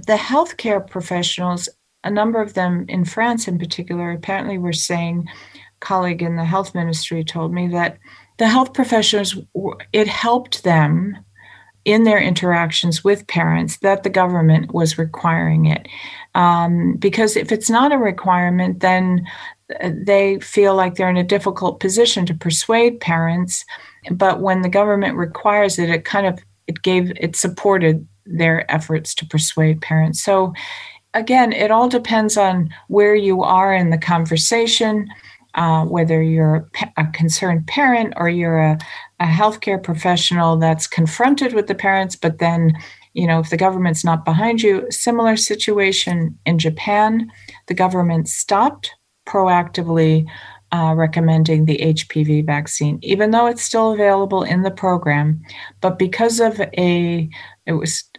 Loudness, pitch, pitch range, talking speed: -17 LUFS, 180 Hz, 165-205 Hz, 150 wpm